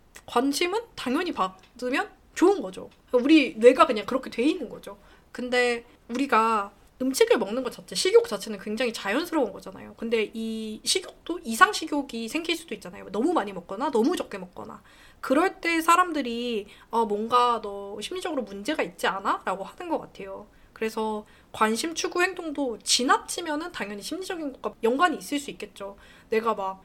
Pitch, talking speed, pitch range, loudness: 250 Hz, 350 characters per minute, 220-330 Hz, -26 LUFS